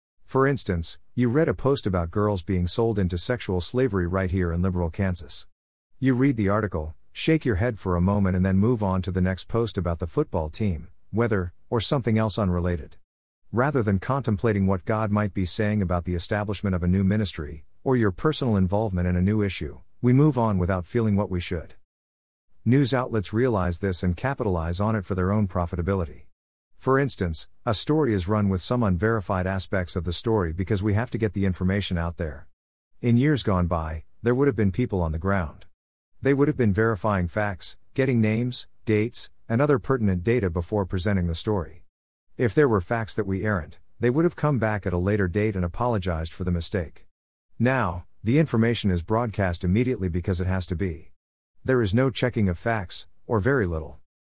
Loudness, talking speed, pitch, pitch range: -25 LUFS, 200 wpm, 100 Hz, 90-115 Hz